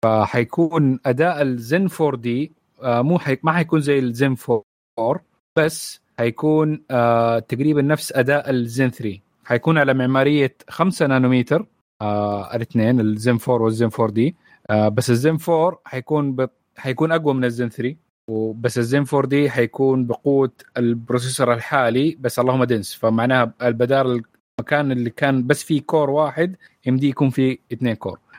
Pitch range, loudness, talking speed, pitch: 120-145 Hz, -20 LUFS, 145 wpm, 130 Hz